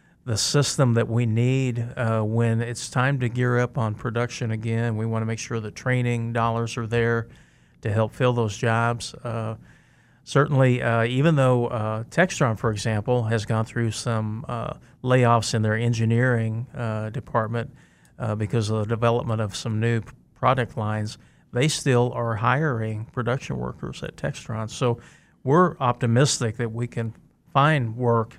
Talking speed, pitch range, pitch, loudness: 160 wpm, 115-125 Hz, 120 Hz, -24 LUFS